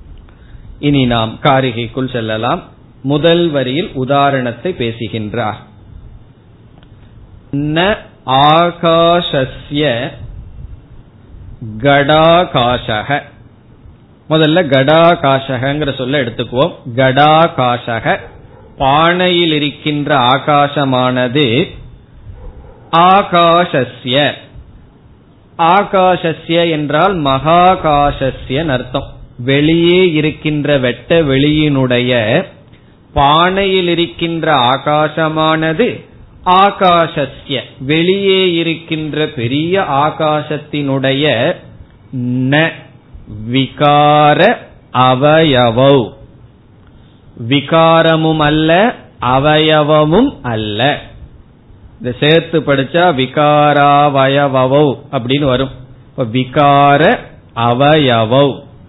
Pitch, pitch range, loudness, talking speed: 140 Hz, 125-155 Hz, -12 LUFS, 45 wpm